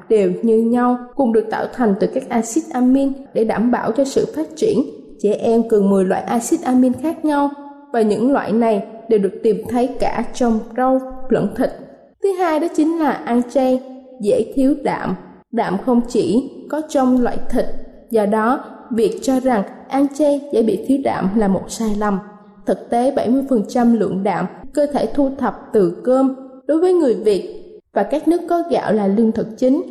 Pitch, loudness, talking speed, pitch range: 250 Hz, -18 LUFS, 195 wpm, 220-275 Hz